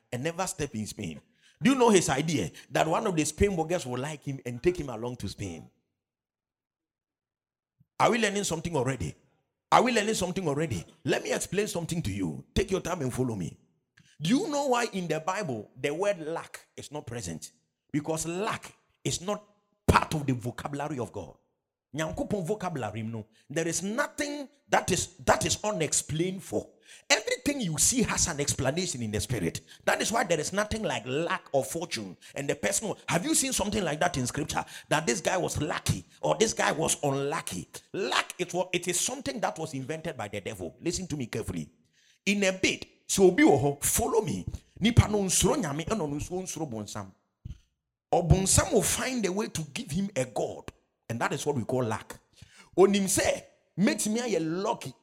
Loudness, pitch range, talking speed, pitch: -29 LUFS, 130-200 Hz, 180 wpm, 165 Hz